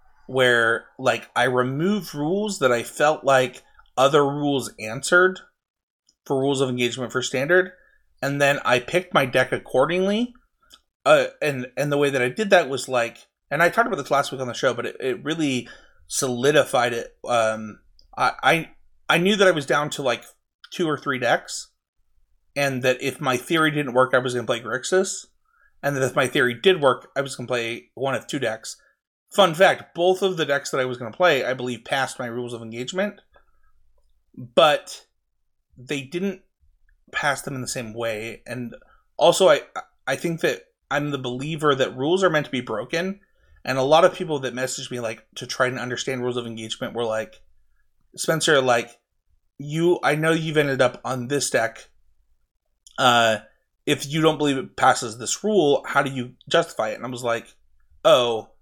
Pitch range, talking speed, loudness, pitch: 125-165 Hz, 190 wpm, -22 LUFS, 135 Hz